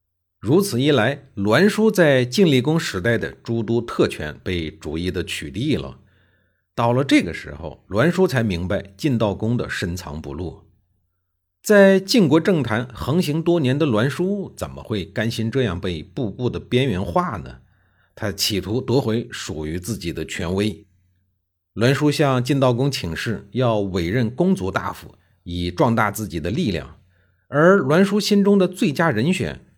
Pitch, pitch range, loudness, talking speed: 110 Hz, 90-145 Hz, -20 LUFS, 230 characters per minute